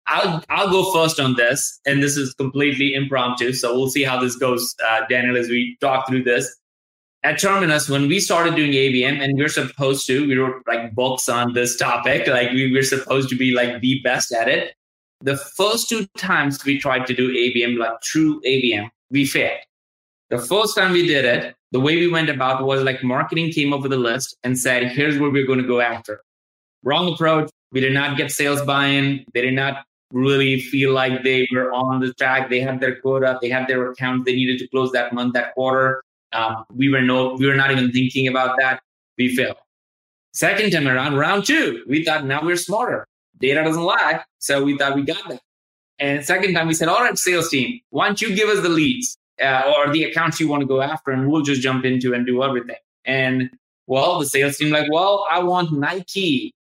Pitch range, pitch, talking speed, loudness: 125-150 Hz, 135 Hz, 215 wpm, -19 LUFS